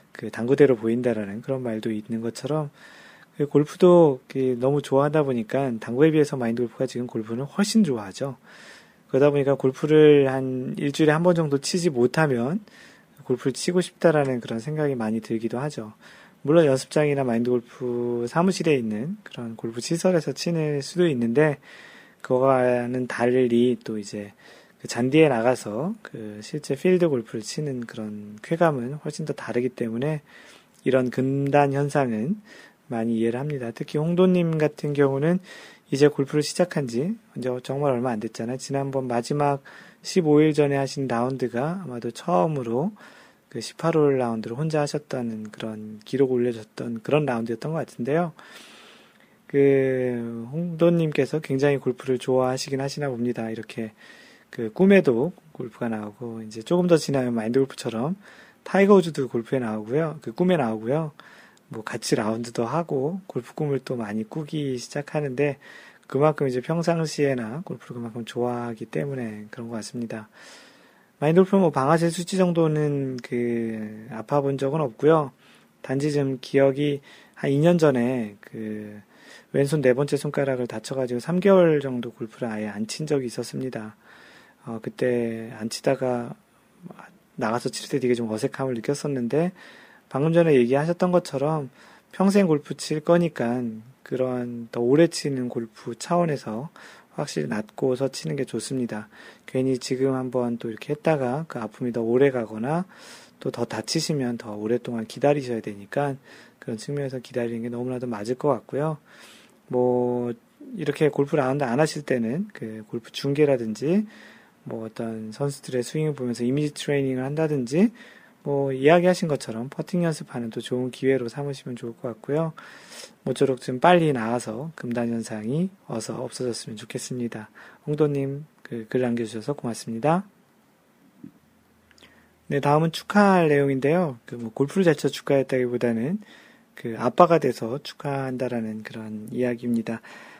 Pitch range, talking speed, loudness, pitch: 120-155 Hz, 325 characters per minute, -24 LUFS, 135 Hz